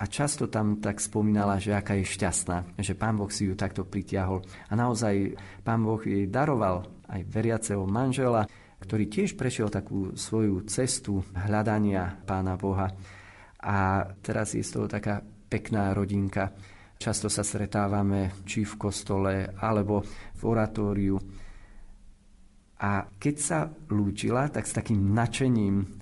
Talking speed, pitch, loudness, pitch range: 135 wpm, 100 Hz, -29 LUFS, 95-110 Hz